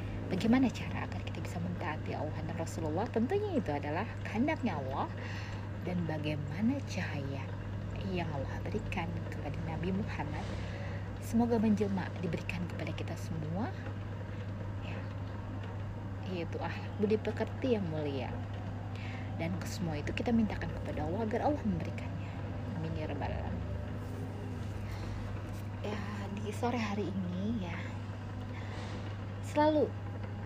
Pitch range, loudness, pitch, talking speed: 95-105 Hz, -36 LUFS, 100 Hz, 110 wpm